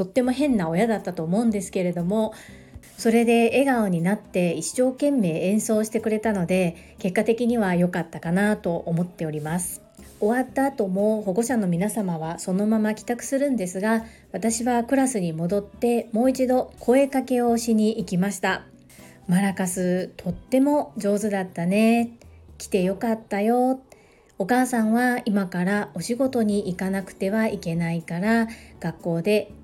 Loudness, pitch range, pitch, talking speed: -23 LUFS, 185-235 Hz, 210 Hz, 320 characters per minute